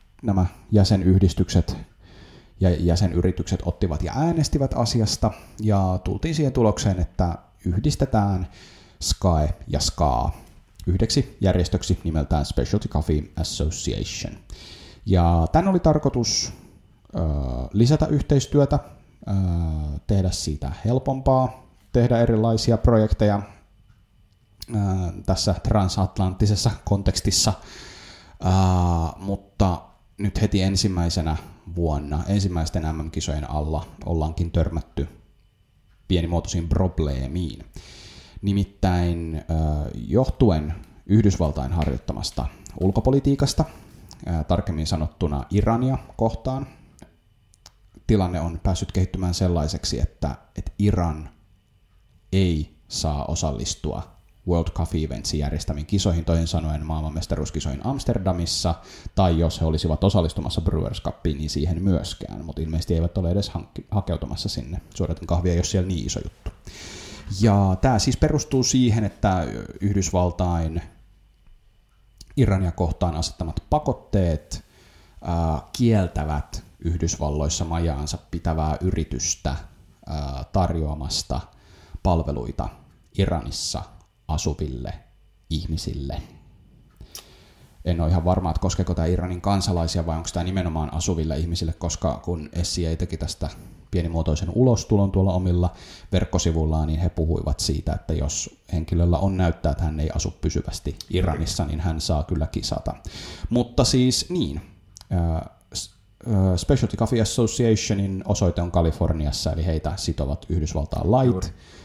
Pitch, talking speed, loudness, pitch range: 90 Hz, 100 wpm, -24 LUFS, 80-100 Hz